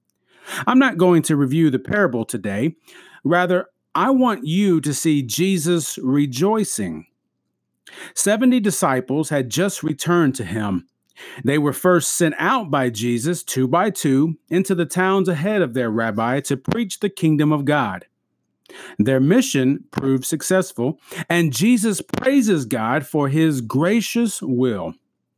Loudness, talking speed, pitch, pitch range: -19 LUFS, 135 wpm, 160 Hz, 130-190 Hz